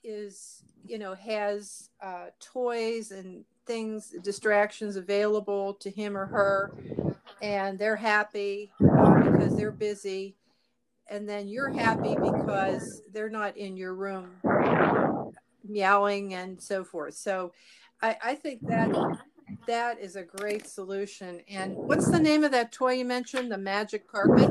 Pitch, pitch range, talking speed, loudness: 205 Hz, 195-220 Hz, 135 wpm, -28 LUFS